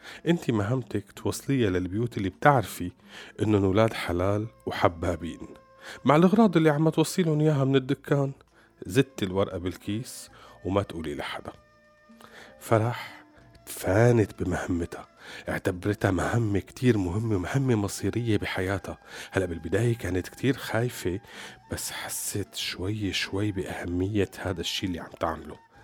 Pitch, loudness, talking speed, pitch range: 105 Hz, -27 LUFS, 115 wpm, 95-125 Hz